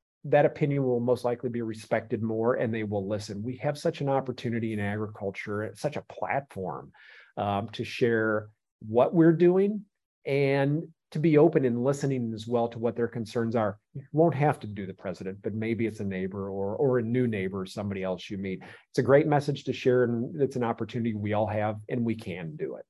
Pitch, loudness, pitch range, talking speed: 115 Hz, -28 LUFS, 105-135 Hz, 210 wpm